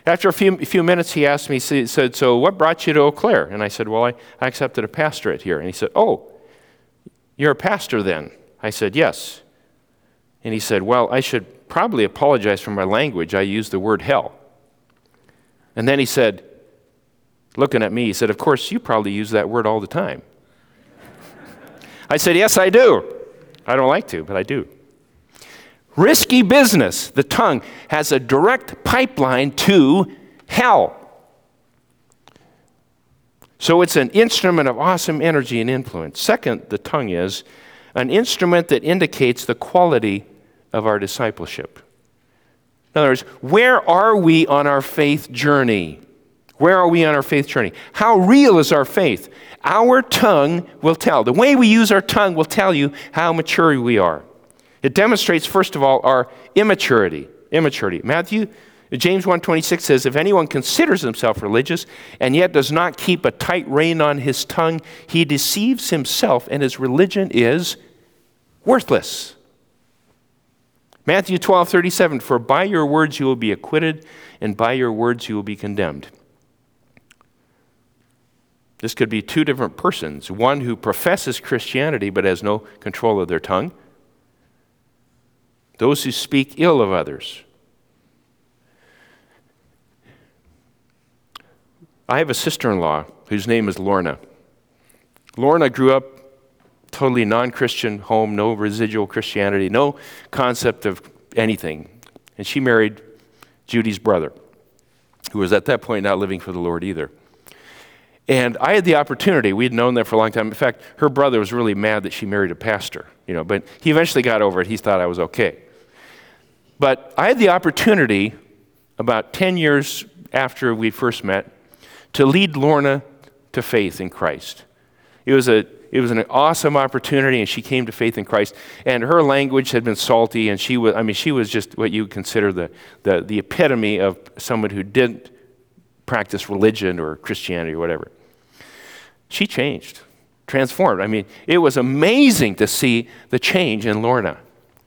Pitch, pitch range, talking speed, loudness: 130 Hz, 110-160 Hz, 160 wpm, -17 LUFS